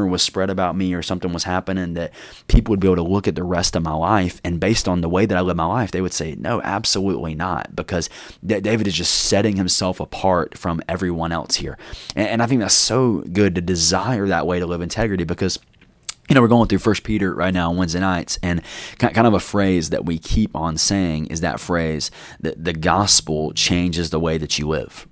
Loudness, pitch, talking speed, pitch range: -19 LUFS, 90 Hz, 230 wpm, 85-100 Hz